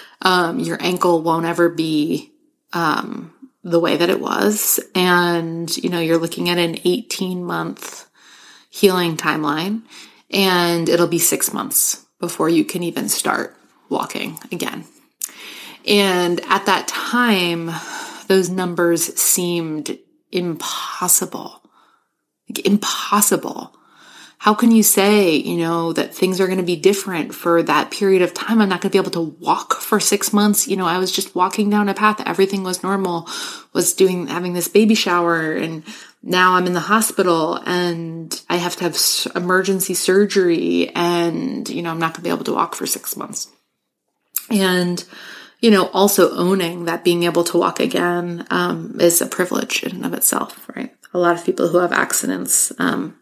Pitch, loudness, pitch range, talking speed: 180 Hz, -18 LUFS, 170-200 Hz, 165 wpm